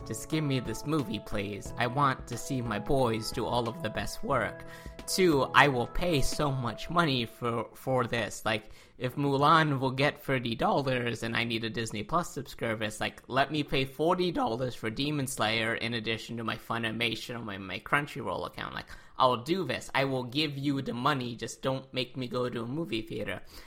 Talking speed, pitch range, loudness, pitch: 205 wpm, 110-140 Hz, -30 LUFS, 125 Hz